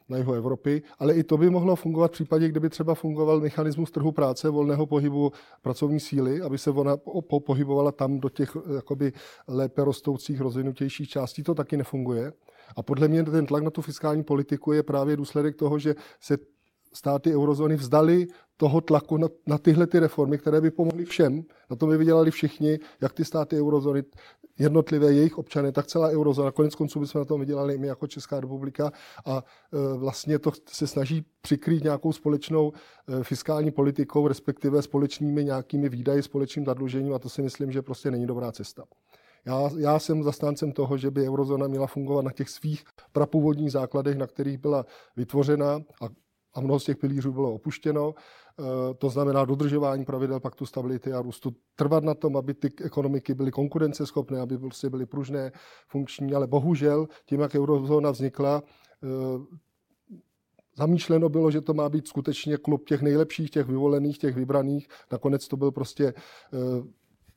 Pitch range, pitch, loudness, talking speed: 140-155 Hz, 145 Hz, -26 LUFS, 170 wpm